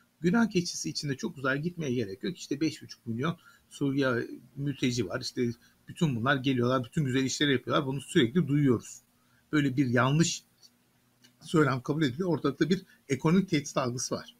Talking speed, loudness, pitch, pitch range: 155 wpm, -29 LUFS, 140 Hz, 125-160 Hz